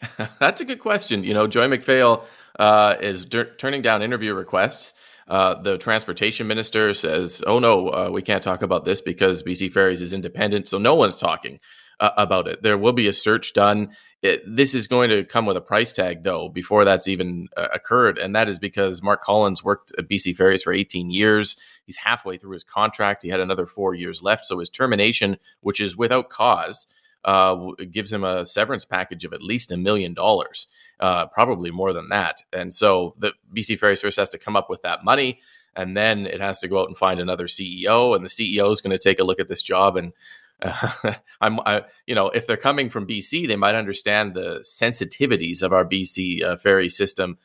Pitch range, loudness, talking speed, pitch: 95-110 Hz, -21 LUFS, 215 wpm, 100 Hz